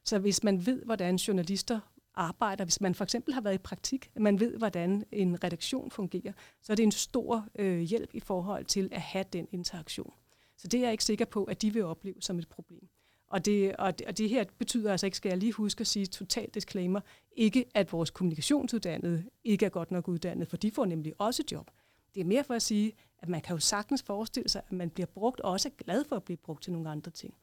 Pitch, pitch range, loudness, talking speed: 200 Hz, 180-225 Hz, -32 LUFS, 245 wpm